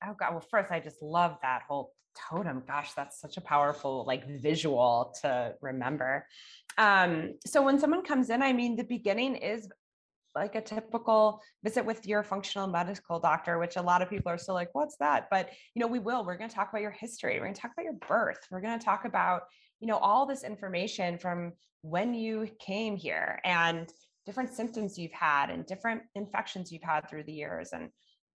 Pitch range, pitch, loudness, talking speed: 165-225 Hz, 195 Hz, -31 LUFS, 205 wpm